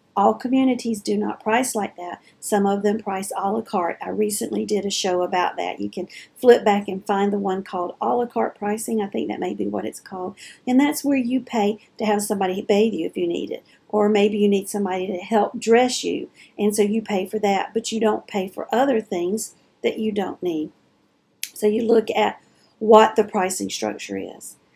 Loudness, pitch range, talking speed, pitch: -22 LUFS, 195-225 Hz, 220 wpm, 210 Hz